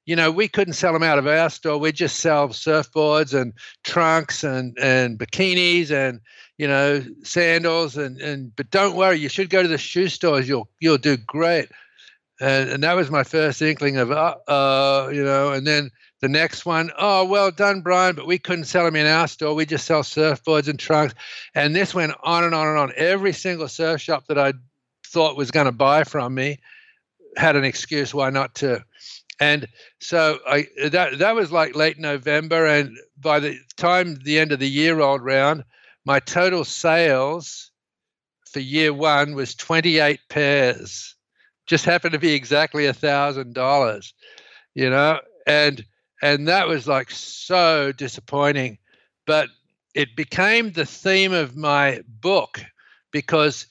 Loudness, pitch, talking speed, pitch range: -20 LUFS, 150 Hz, 175 wpm, 140-165 Hz